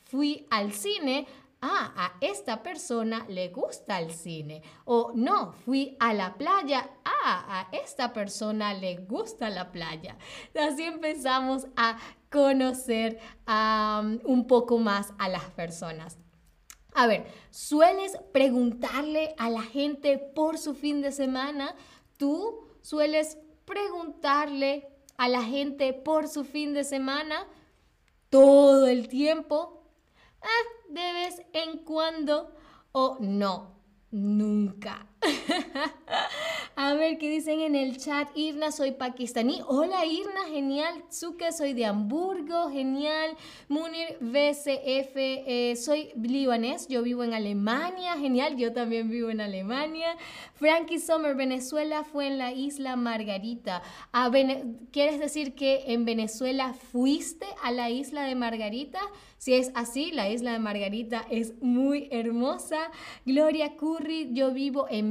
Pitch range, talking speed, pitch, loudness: 235-305 Hz, 125 wpm, 270 Hz, -28 LUFS